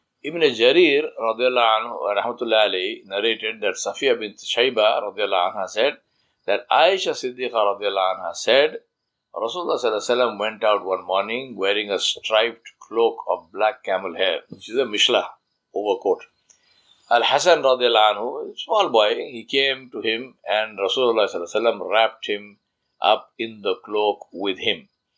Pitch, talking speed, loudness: 125 Hz, 125 wpm, -21 LUFS